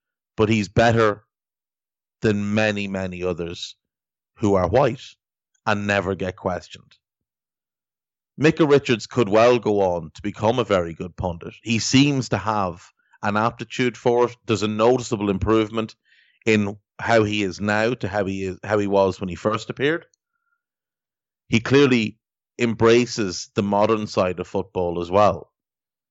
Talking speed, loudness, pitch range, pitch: 145 wpm, -21 LUFS, 100-120 Hz, 110 Hz